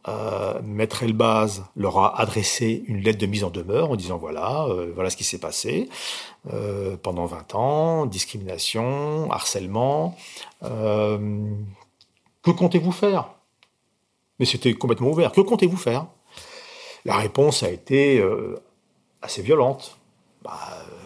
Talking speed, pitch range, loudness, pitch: 135 wpm, 105-160 Hz, -23 LUFS, 115 Hz